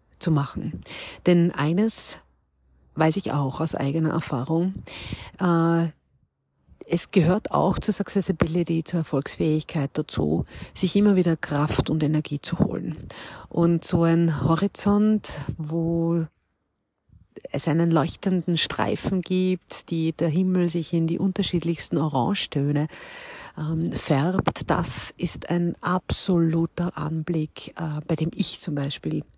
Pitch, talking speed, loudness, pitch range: 165 Hz, 110 wpm, -24 LUFS, 150-175 Hz